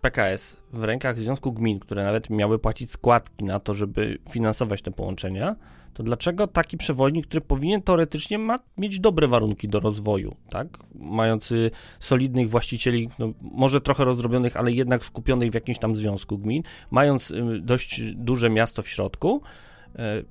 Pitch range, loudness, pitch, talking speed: 110-135 Hz, -24 LUFS, 120 Hz, 155 wpm